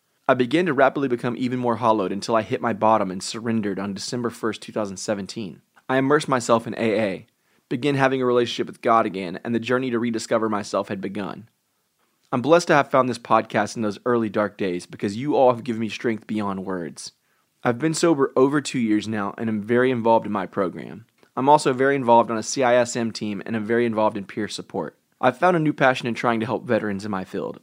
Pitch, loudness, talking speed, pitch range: 115 Hz, -22 LUFS, 220 wpm, 110-130 Hz